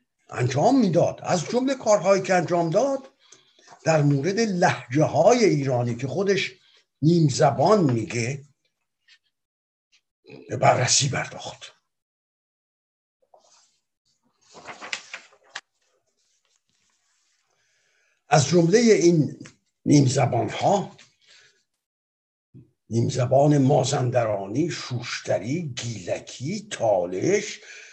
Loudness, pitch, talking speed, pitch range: -22 LUFS, 150 Hz, 70 wpm, 125-185 Hz